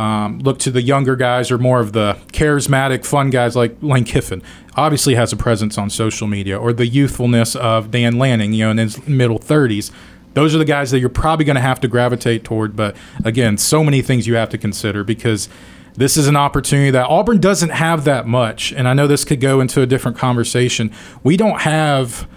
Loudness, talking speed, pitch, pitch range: -15 LUFS, 215 wpm, 125 Hz, 110-140 Hz